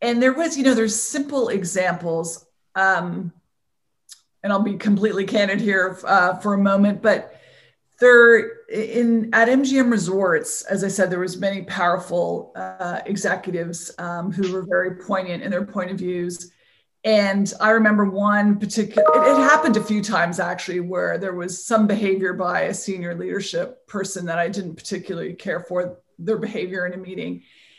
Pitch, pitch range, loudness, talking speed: 195 Hz, 180-215 Hz, -20 LUFS, 165 wpm